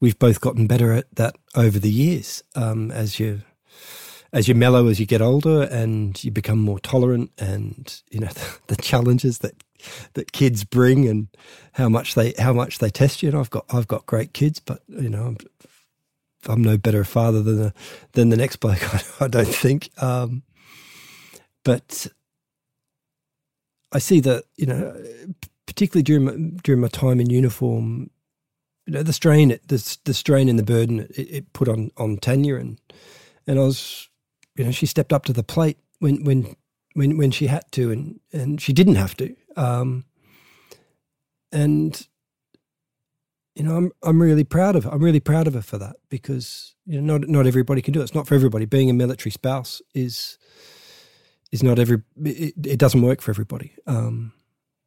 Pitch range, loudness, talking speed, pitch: 115-150 Hz, -20 LUFS, 185 wpm, 130 Hz